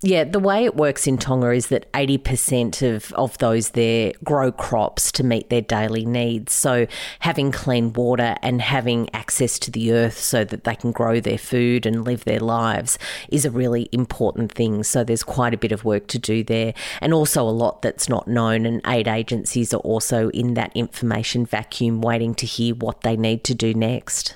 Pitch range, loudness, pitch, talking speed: 115-125 Hz, -21 LUFS, 120 Hz, 200 wpm